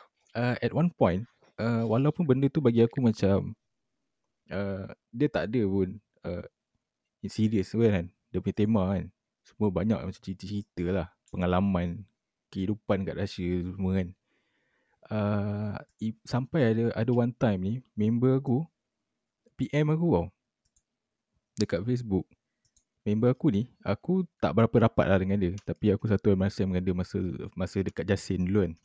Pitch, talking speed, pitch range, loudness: 105 Hz, 155 wpm, 95-120 Hz, -29 LUFS